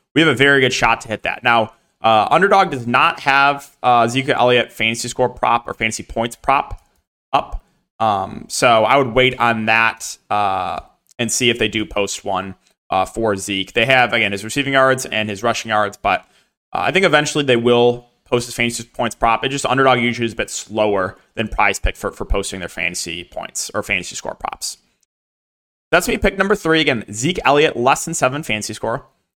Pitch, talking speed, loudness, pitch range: 120 Hz, 205 wpm, -17 LUFS, 110-135 Hz